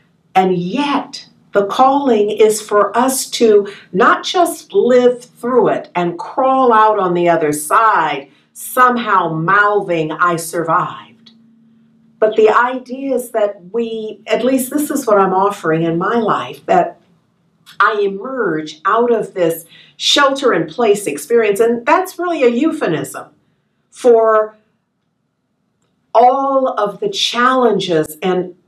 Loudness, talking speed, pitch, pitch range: -14 LUFS, 130 wpm, 215 Hz, 190-245 Hz